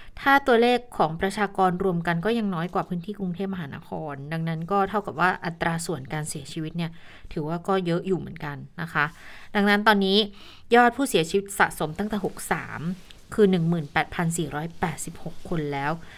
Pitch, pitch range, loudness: 180 Hz, 160-200 Hz, -25 LUFS